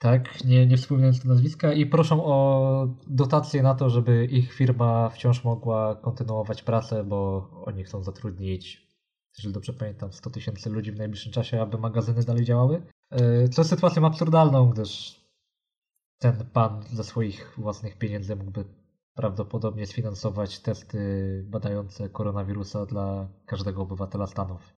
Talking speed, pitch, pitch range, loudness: 140 wpm, 115 Hz, 105-125 Hz, -25 LUFS